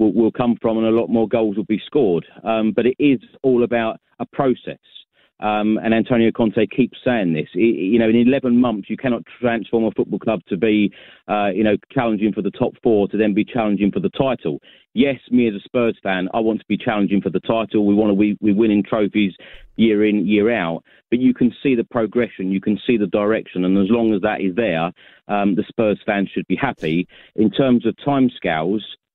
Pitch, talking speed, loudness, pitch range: 110 Hz, 225 wpm, -19 LUFS, 105-120 Hz